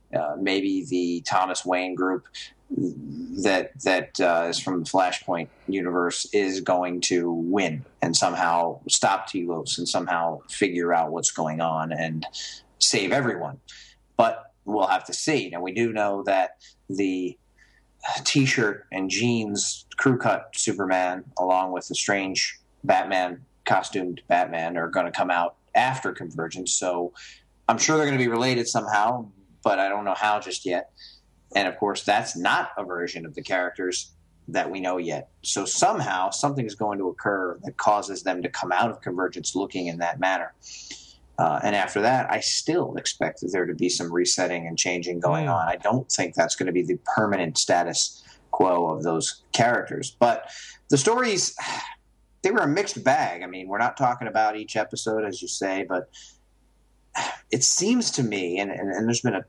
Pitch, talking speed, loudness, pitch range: 95 Hz, 175 wpm, -25 LUFS, 85-105 Hz